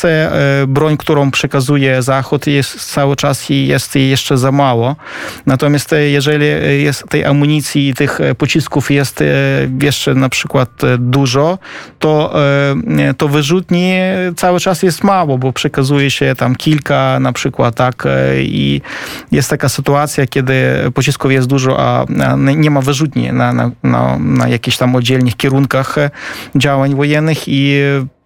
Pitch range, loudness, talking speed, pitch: 130-150 Hz, -12 LUFS, 135 wpm, 140 Hz